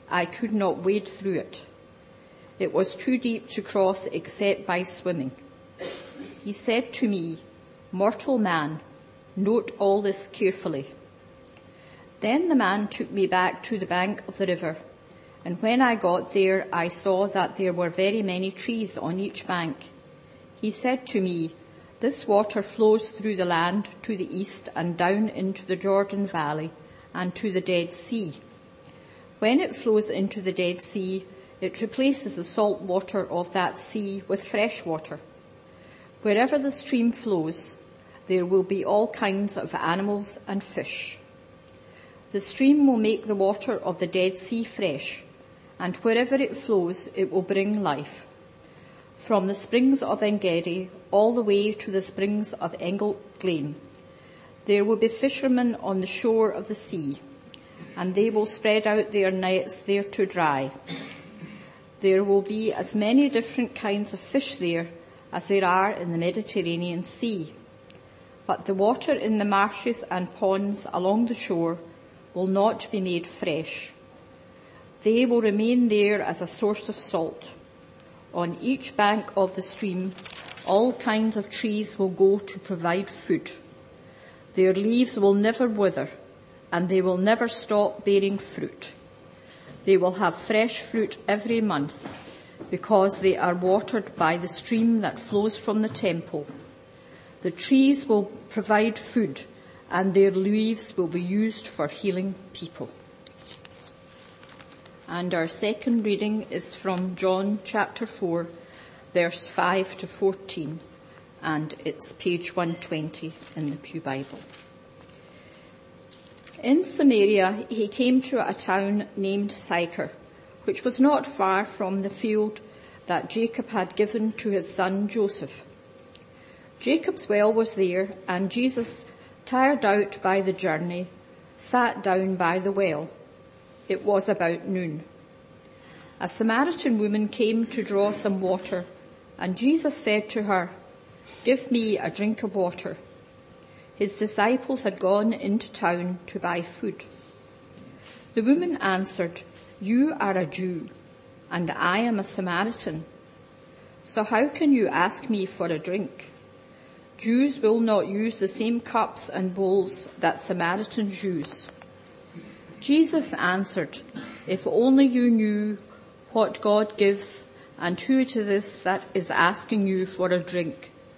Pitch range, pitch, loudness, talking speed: 180-220 Hz, 200 Hz, -25 LUFS, 145 wpm